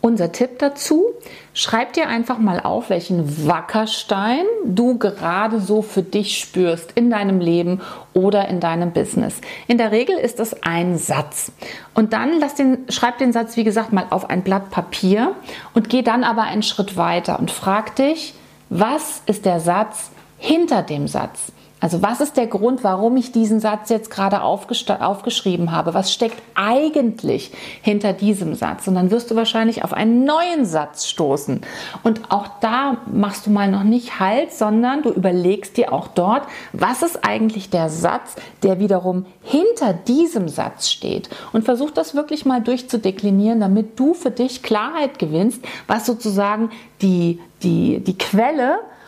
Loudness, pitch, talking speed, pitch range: -19 LUFS, 220 Hz, 165 wpm, 190-245 Hz